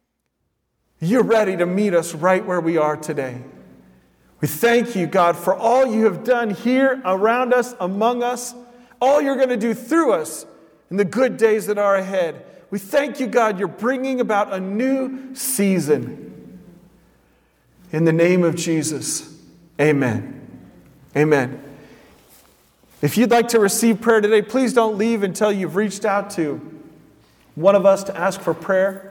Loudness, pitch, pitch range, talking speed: -19 LUFS, 200 Hz, 170-235 Hz, 160 wpm